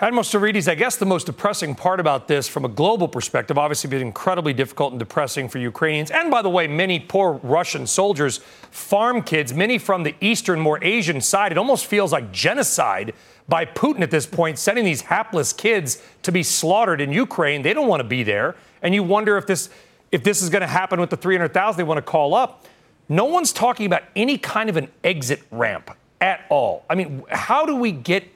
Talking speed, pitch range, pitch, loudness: 215 wpm, 150-205 Hz, 180 Hz, -20 LUFS